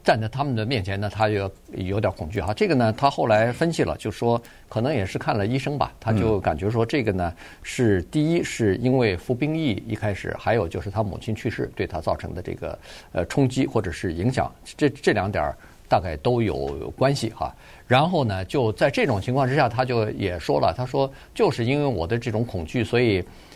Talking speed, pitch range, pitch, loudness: 305 characters per minute, 105-130 Hz, 115 Hz, -24 LUFS